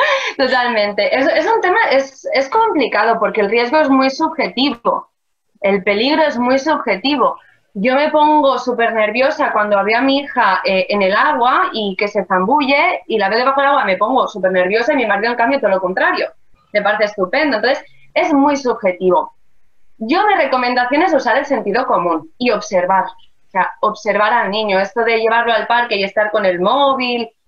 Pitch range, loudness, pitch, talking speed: 205-280 Hz, -15 LUFS, 235 Hz, 190 wpm